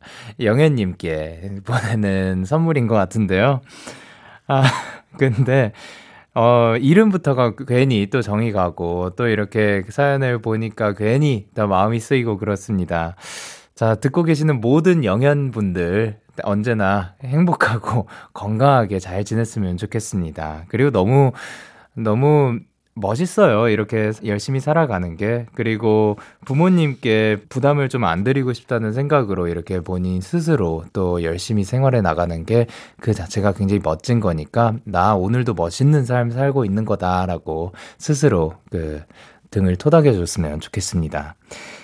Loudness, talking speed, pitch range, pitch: -19 LUFS, 285 characters per minute, 95-135 Hz, 110 Hz